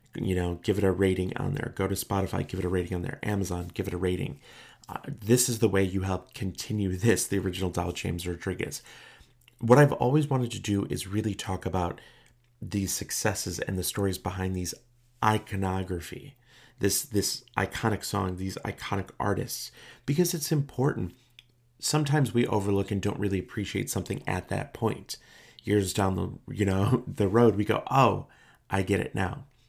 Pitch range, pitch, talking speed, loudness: 95-120 Hz, 100 Hz, 180 wpm, -28 LUFS